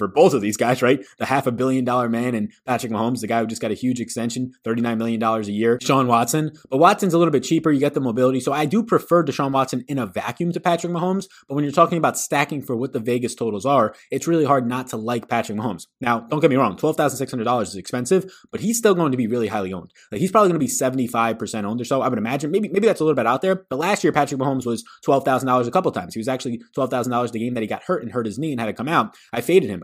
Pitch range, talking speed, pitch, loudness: 120-150 Hz, 300 wpm, 130 Hz, -21 LUFS